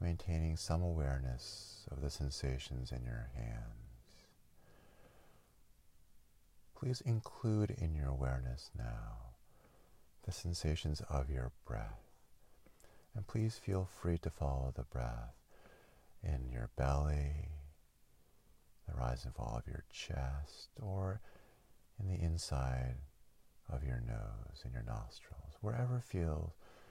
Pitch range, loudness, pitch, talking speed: 65-95 Hz, -42 LUFS, 75 Hz, 110 wpm